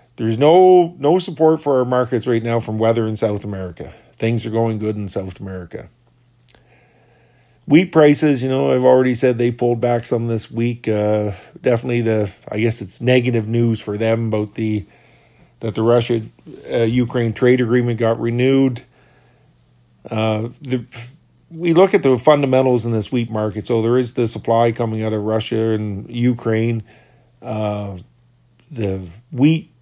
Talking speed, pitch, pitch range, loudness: 160 wpm, 115 Hz, 110-125 Hz, -17 LUFS